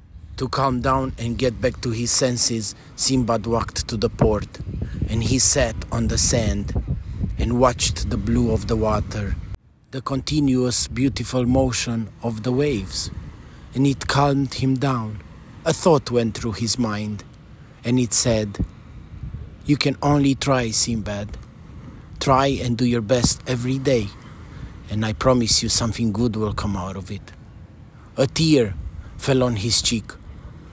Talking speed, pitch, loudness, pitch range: 150 wpm, 115 Hz, -21 LUFS, 105-130 Hz